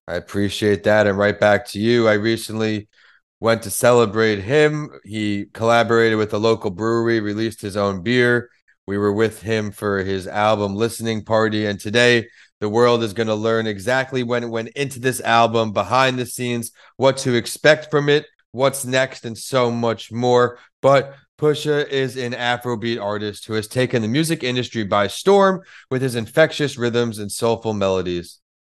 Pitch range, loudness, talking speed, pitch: 105-125 Hz, -19 LUFS, 175 wpm, 115 Hz